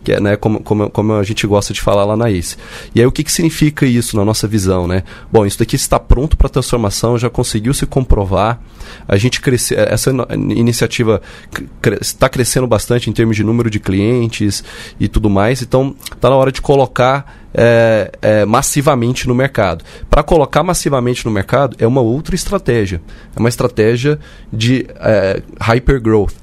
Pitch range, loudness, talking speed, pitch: 105-130 Hz, -14 LUFS, 185 wpm, 115 Hz